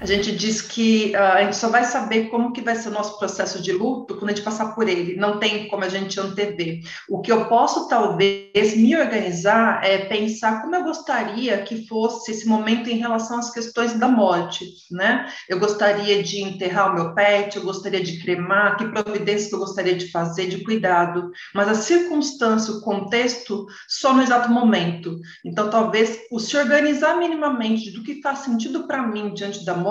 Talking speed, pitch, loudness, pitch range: 195 wpm, 215 Hz, -21 LUFS, 195-235 Hz